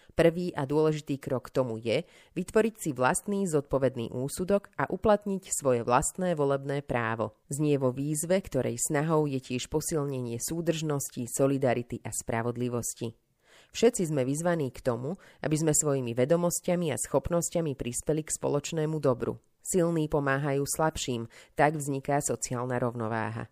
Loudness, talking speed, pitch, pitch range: -29 LUFS, 135 wpm, 140 Hz, 125-165 Hz